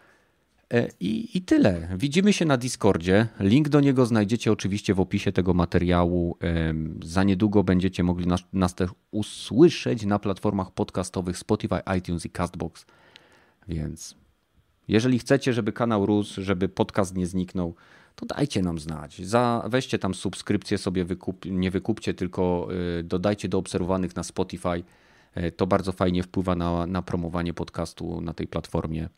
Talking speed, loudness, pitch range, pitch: 145 wpm, -25 LUFS, 90-105 Hz, 95 Hz